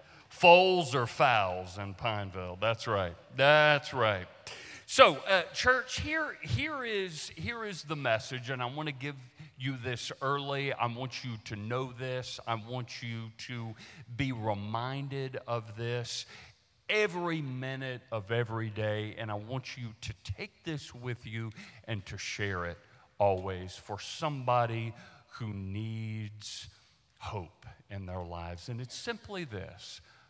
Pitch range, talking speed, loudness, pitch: 110-140 Hz, 145 wpm, -32 LUFS, 120 Hz